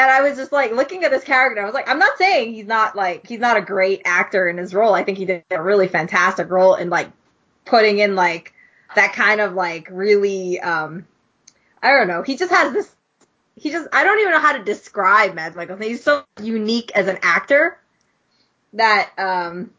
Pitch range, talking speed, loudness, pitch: 185-265 Hz, 215 wpm, -17 LUFS, 210 Hz